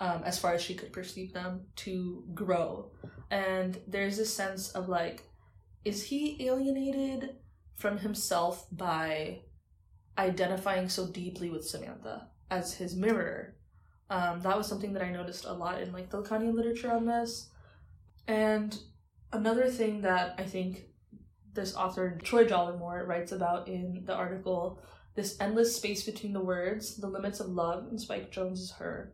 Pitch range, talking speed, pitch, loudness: 180-210 Hz, 155 wpm, 185 Hz, -33 LUFS